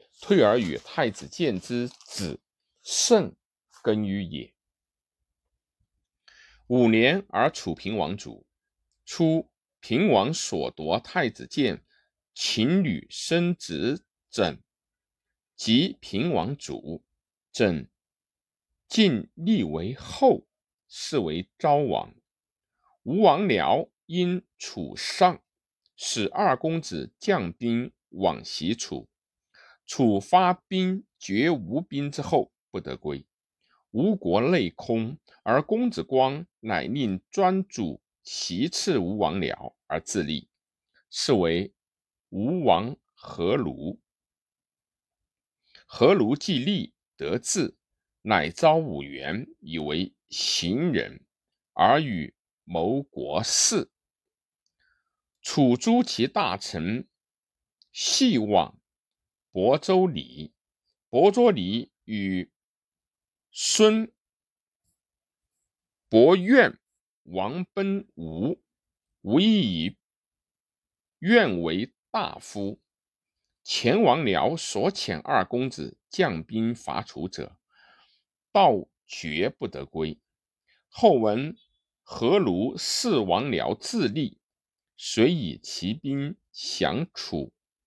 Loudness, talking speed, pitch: -25 LUFS, 120 characters per minute, 145 Hz